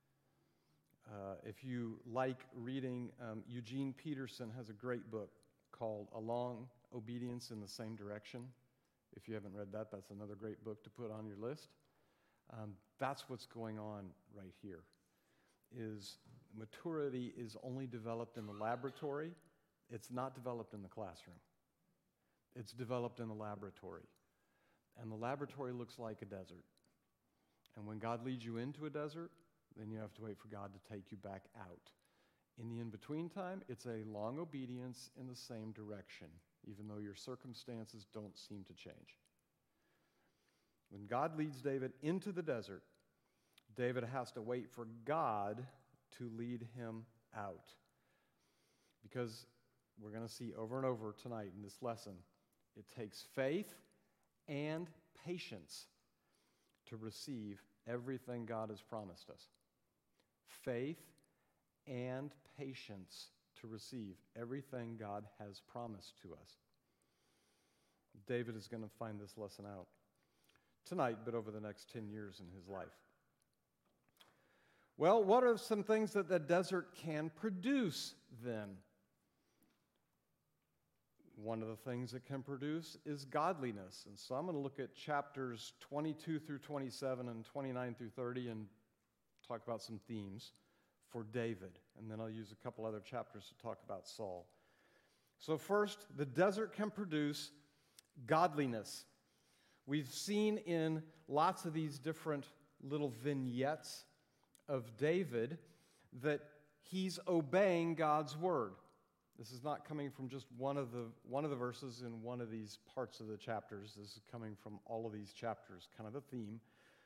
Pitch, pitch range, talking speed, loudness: 120 Hz, 110-140 Hz, 150 wpm, -44 LUFS